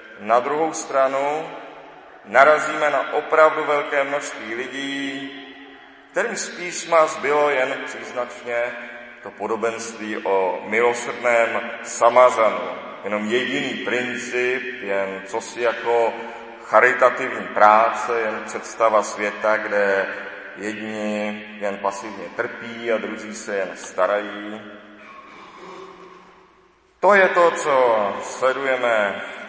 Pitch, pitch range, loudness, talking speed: 120 Hz, 105-140 Hz, -20 LUFS, 95 wpm